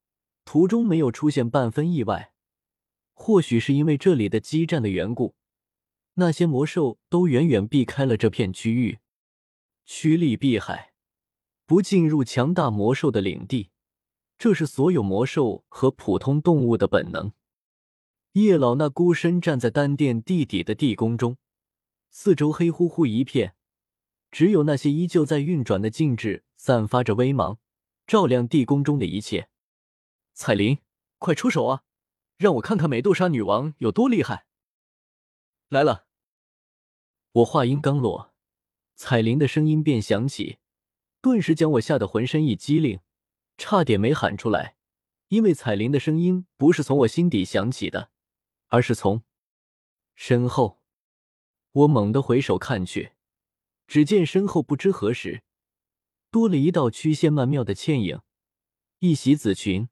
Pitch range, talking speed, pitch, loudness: 110-160 Hz, 215 characters per minute, 135 Hz, -22 LUFS